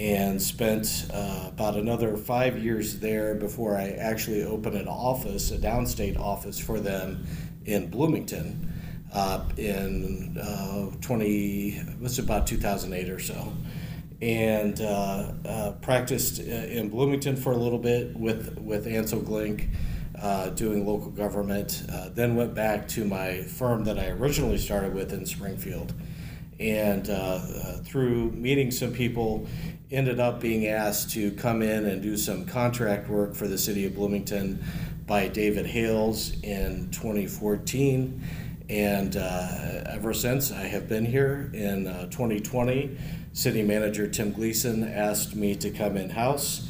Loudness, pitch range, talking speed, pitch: -28 LUFS, 100-120 Hz, 145 wpm, 105 Hz